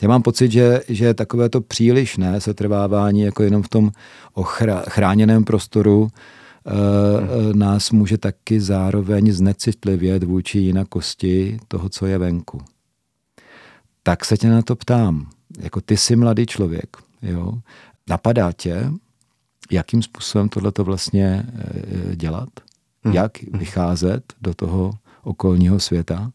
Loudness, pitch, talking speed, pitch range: -18 LUFS, 105 Hz, 120 wpm, 95-115 Hz